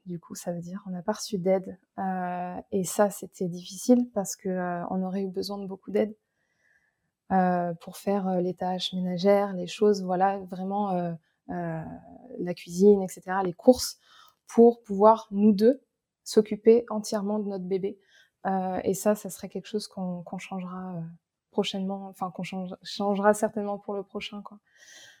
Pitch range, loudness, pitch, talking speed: 185-210 Hz, -27 LUFS, 195 Hz, 170 wpm